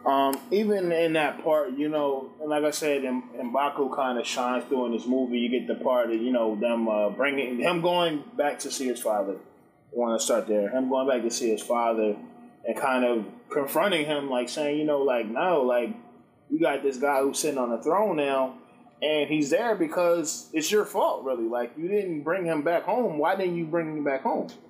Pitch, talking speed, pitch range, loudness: 135 Hz, 225 wpm, 120-155 Hz, -26 LUFS